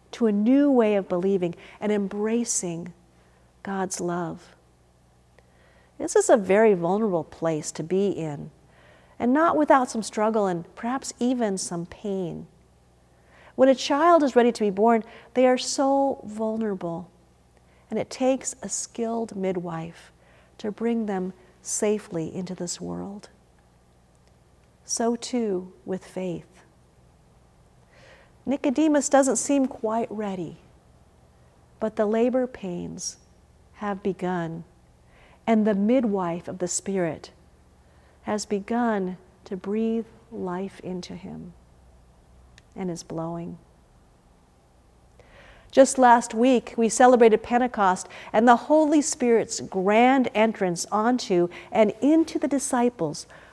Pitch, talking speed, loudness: 190 Hz, 115 wpm, -24 LUFS